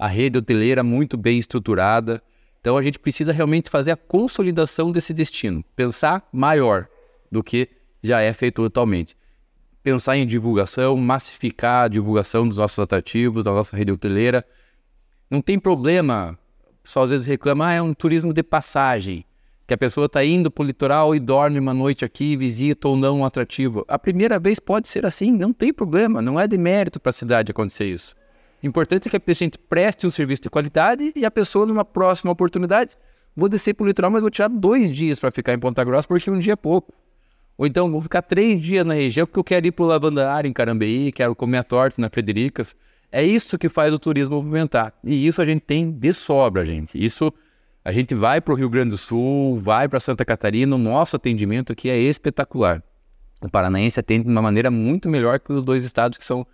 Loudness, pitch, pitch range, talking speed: -20 LUFS, 140 Hz, 120-165 Hz, 205 wpm